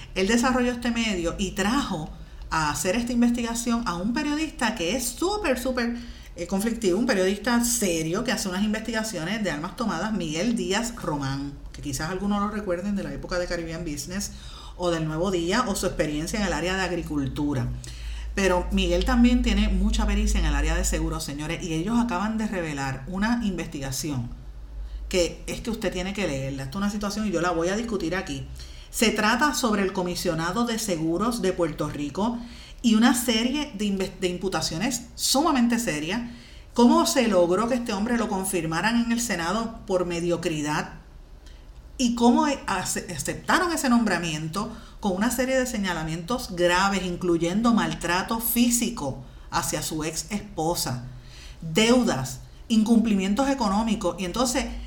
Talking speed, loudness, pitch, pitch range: 155 wpm, -25 LUFS, 190 Hz, 170-230 Hz